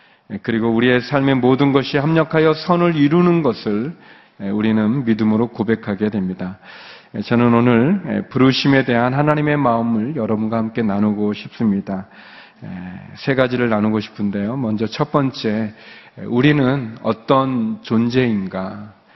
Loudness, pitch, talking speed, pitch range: -17 LUFS, 115 Hz, 290 characters per minute, 110-140 Hz